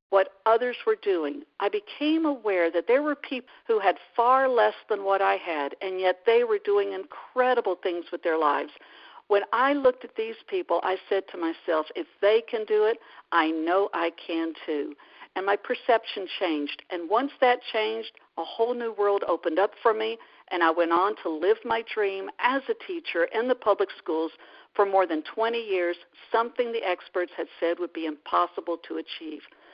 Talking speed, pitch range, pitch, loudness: 190 wpm, 175-255 Hz, 205 Hz, -26 LUFS